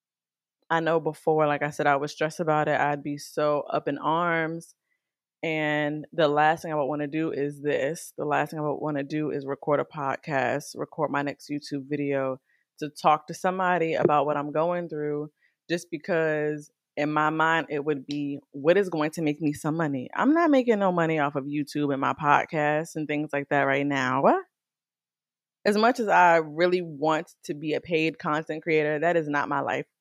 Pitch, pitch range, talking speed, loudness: 150 Hz, 145-165 Hz, 210 wpm, -26 LUFS